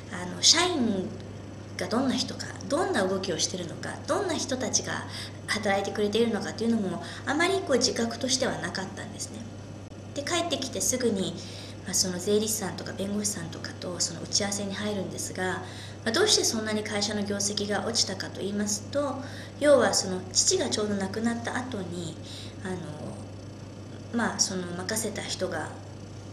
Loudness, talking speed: -27 LUFS, 360 characters per minute